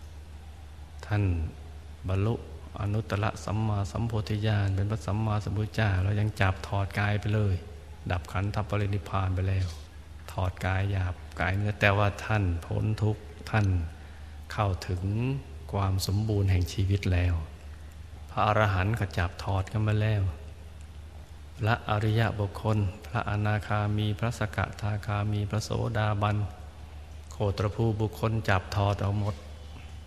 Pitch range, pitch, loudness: 80-105 Hz, 100 Hz, -29 LUFS